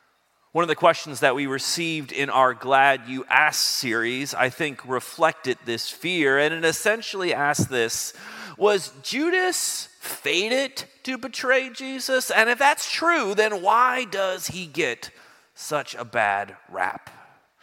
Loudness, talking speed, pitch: -22 LUFS, 145 wpm, 165 Hz